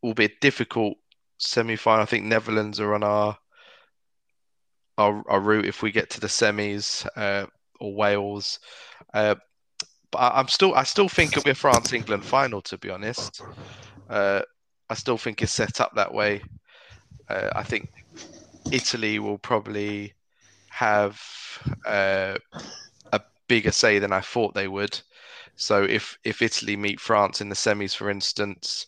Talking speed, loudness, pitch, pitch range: 160 wpm, -24 LUFS, 105 Hz, 100-115 Hz